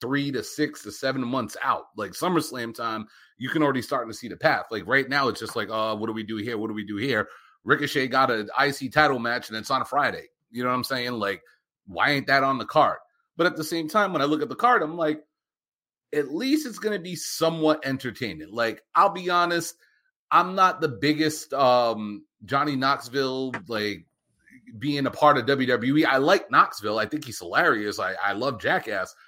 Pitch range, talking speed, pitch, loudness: 120-155 Hz, 215 wpm, 140 Hz, -24 LUFS